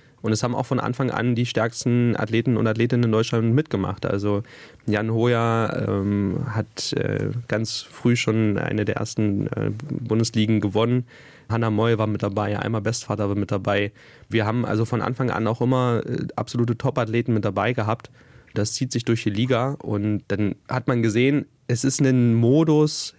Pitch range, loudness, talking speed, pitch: 110-125 Hz, -23 LUFS, 175 wpm, 115 Hz